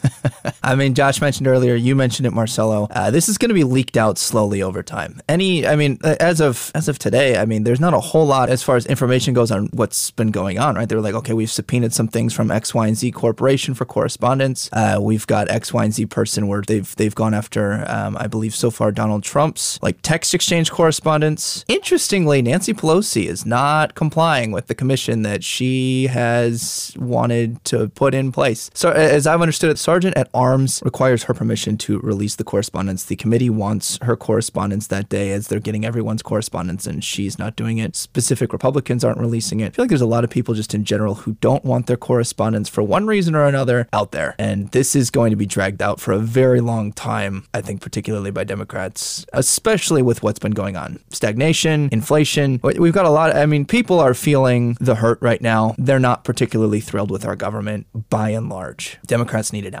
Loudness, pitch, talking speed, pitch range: -18 LUFS, 120 Hz, 220 wpm, 110-140 Hz